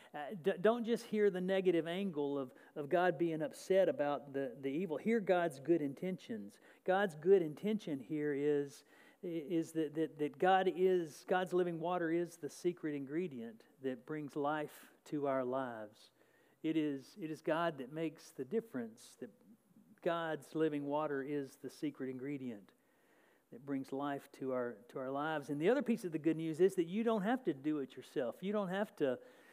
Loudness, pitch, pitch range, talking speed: -38 LUFS, 160 Hz, 145-190 Hz, 185 wpm